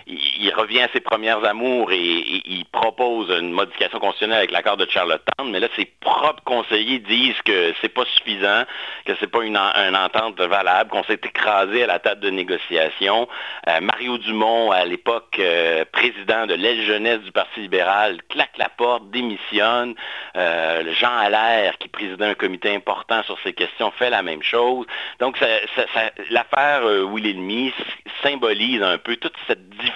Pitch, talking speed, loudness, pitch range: 110 Hz, 180 wpm, -19 LUFS, 95-120 Hz